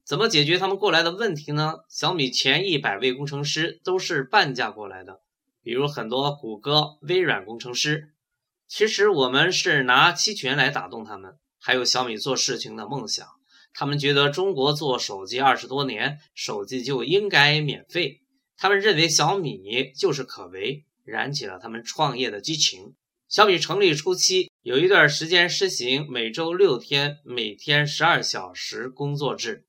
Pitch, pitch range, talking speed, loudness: 150 Hz, 130-185 Hz, 260 characters per minute, -22 LUFS